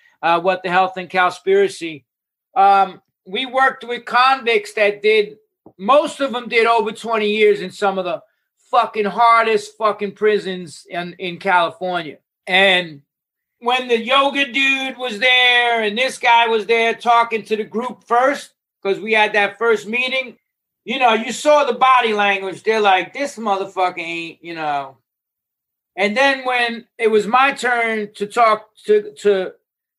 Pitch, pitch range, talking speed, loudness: 220 Hz, 195-250 Hz, 160 wpm, -17 LUFS